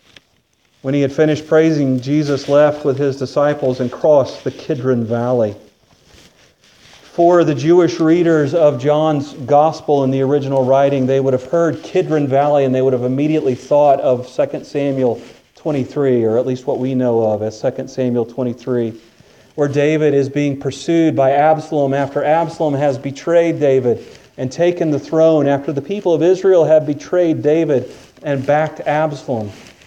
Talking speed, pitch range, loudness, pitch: 160 wpm, 130-155 Hz, -15 LUFS, 145 Hz